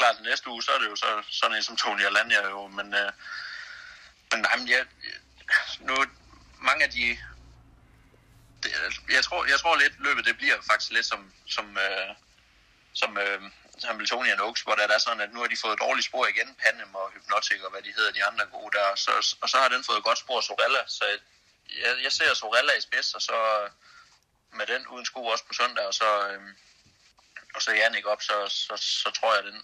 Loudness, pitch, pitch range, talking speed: -25 LUFS, 100 Hz, 100-110 Hz, 235 wpm